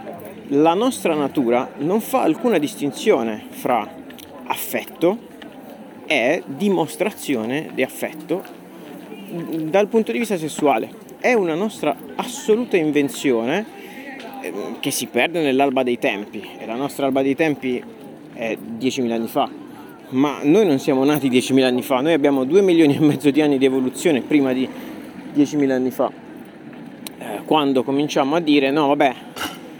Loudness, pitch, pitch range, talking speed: -20 LUFS, 145 Hz, 135-200 Hz, 135 wpm